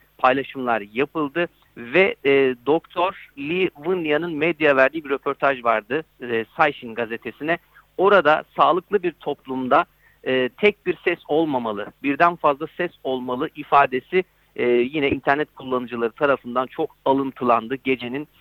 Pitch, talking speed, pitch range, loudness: 140 Hz, 120 wpm, 130-160 Hz, -21 LUFS